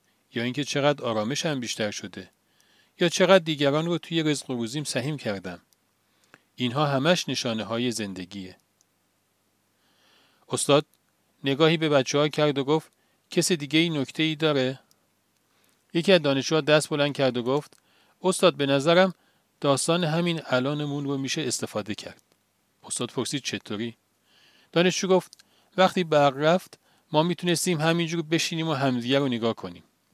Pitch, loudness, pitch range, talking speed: 145 Hz, -25 LUFS, 120-160 Hz, 140 wpm